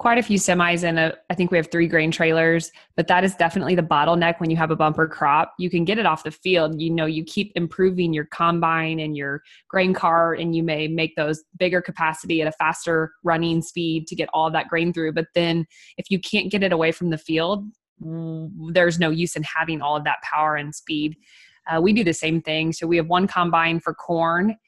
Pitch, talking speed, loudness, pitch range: 165 Hz, 235 wpm, -21 LUFS, 160-175 Hz